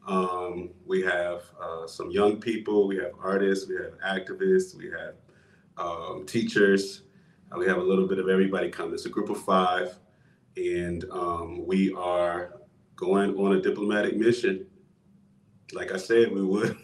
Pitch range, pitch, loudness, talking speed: 90-115 Hz, 95 Hz, -27 LUFS, 160 wpm